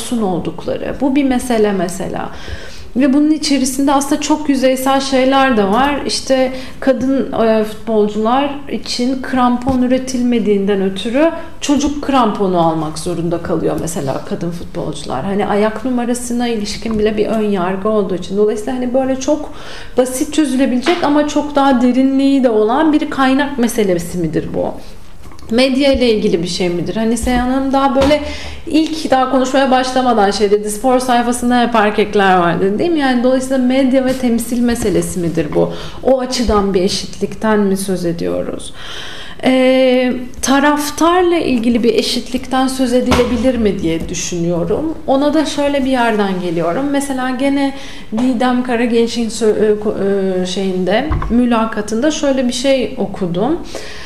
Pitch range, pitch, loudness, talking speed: 210-270 Hz, 245 Hz, -15 LUFS, 135 wpm